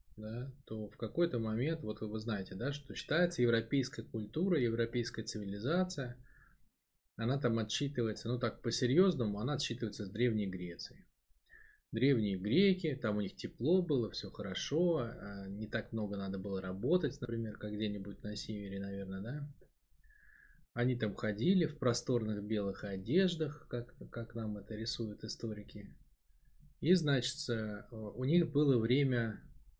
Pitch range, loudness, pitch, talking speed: 105-140 Hz, -36 LUFS, 115 Hz, 140 wpm